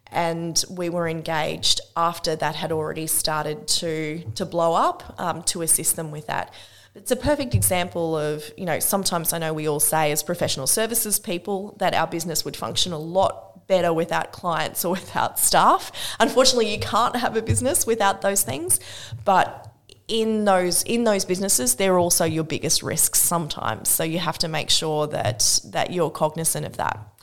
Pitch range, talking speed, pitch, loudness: 155-190 Hz, 180 wpm, 170 Hz, -22 LUFS